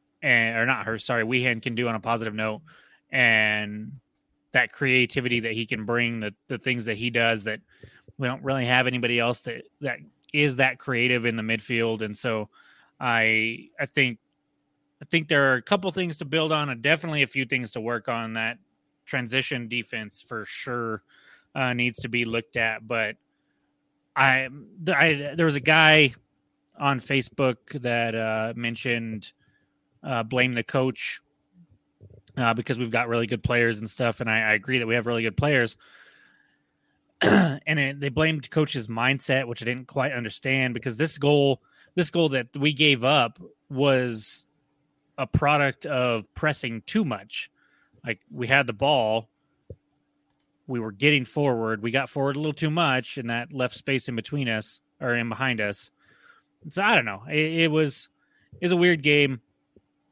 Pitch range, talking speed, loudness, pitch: 115-140 Hz, 175 wpm, -24 LUFS, 125 Hz